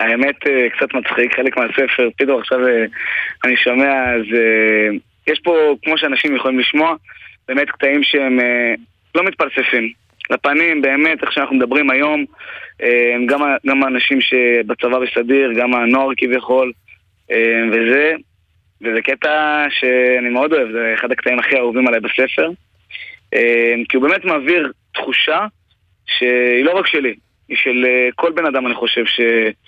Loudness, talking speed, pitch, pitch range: -15 LUFS, 130 wpm, 125 Hz, 115-140 Hz